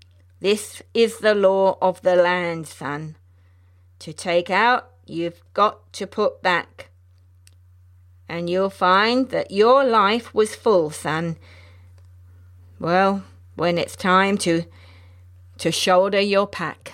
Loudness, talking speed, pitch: -20 LUFS, 120 wpm, 165 Hz